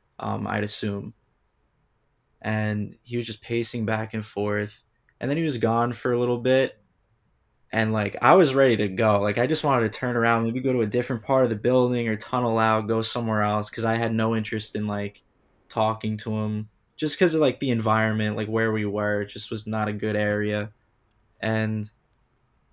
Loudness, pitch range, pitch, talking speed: -24 LUFS, 105-120 Hz, 110 Hz, 205 wpm